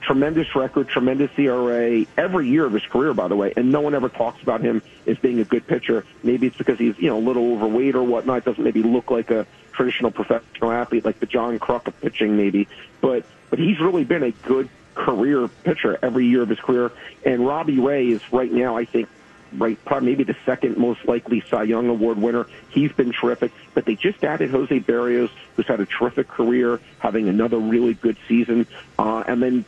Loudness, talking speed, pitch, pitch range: -21 LUFS, 210 wpm, 120 Hz, 115-125 Hz